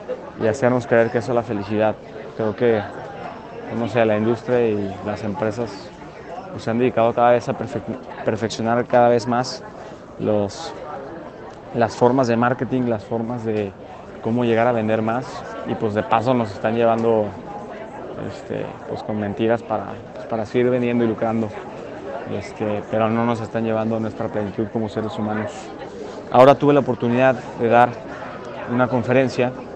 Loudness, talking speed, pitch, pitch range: -20 LUFS, 165 wpm, 115 Hz, 110-120 Hz